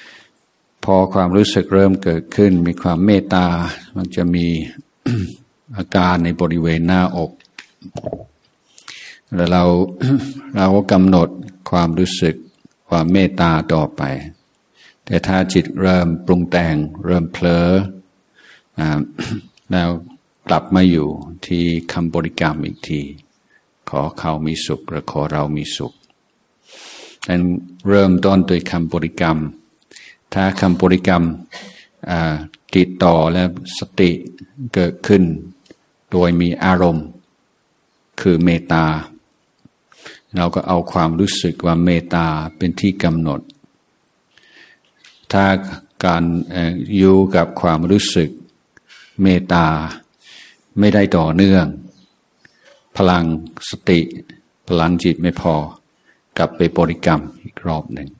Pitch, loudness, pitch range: 90 Hz, -16 LUFS, 85-95 Hz